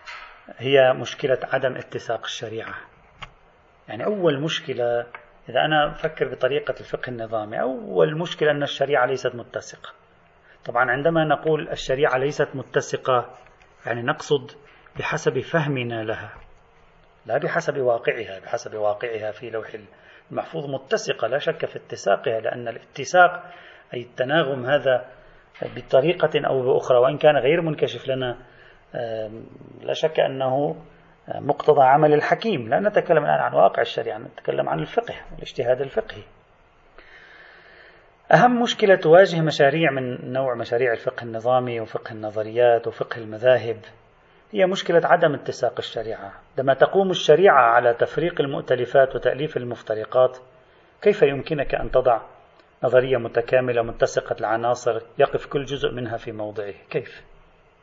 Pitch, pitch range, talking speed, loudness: 130 Hz, 120-150 Hz, 120 wpm, -22 LUFS